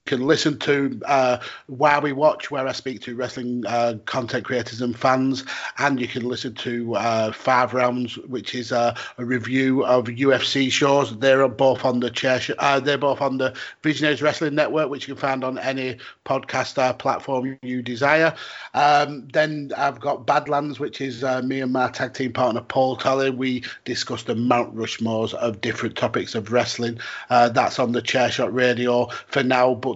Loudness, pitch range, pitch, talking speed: -22 LUFS, 125-140 Hz, 130 Hz, 185 wpm